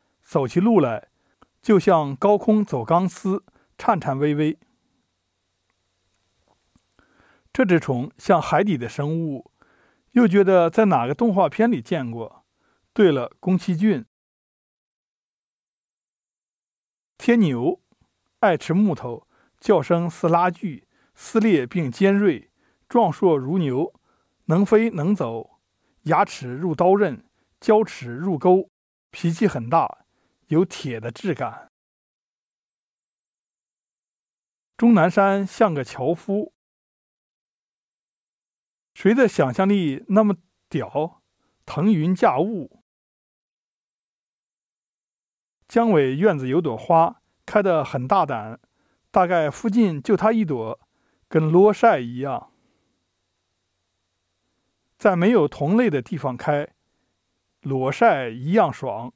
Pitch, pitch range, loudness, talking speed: 170 Hz, 130-205 Hz, -21 LUFS, 145 characters per minute